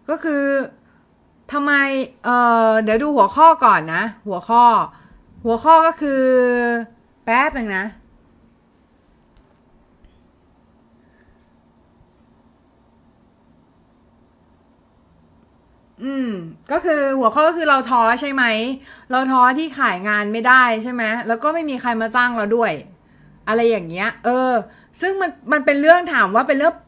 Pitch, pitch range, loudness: 250 Hz, 230-295 Hz, -17 LUFS